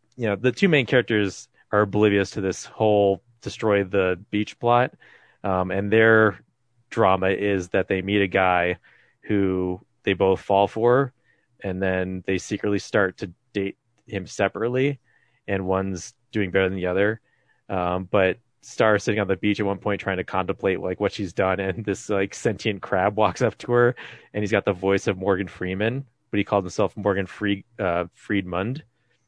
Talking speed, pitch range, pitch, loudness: 180 wpm, 95-110 Hz, 100 Hz, -23 LUFS